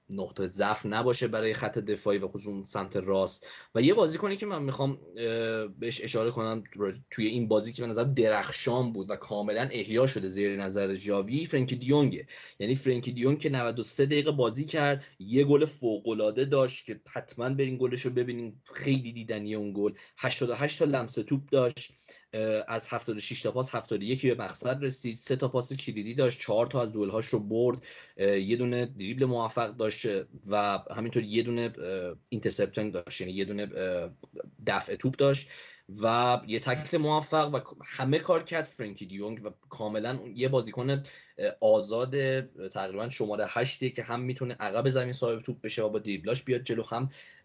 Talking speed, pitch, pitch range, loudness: 170 wpm, 120 Hz, 110-130 Hz, -30 LUFS